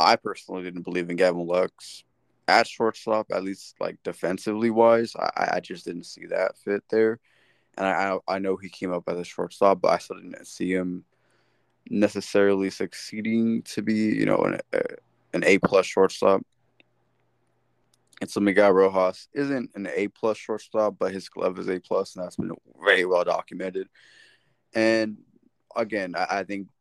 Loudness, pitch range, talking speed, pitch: -25 LUFS, 95-110 Hz, 170 wpm, 100 Hz